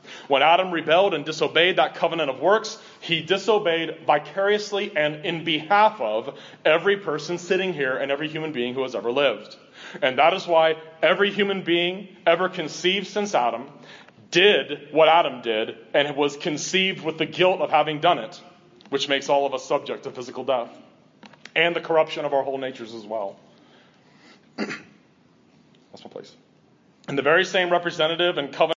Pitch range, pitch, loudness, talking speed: 145-185 Hz, 165 Hz, -22 LUFS, 170 wpm